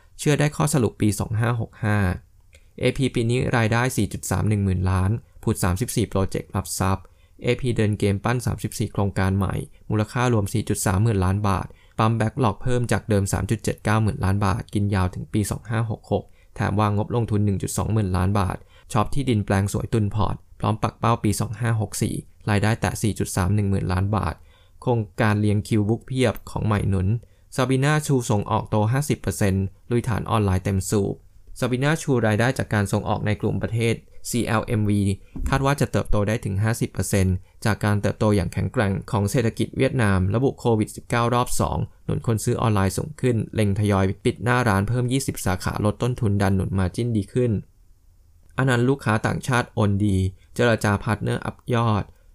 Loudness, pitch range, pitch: -23 LUFS, 95-120 Hz, 105 Hz